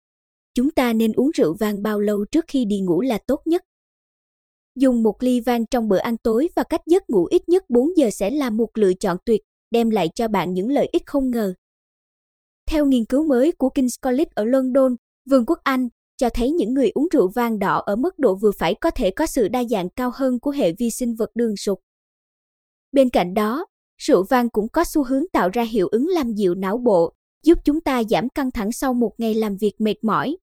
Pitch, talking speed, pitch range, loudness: 245 Hz, 230 wpm, 215-285 Hz, -20 LUFS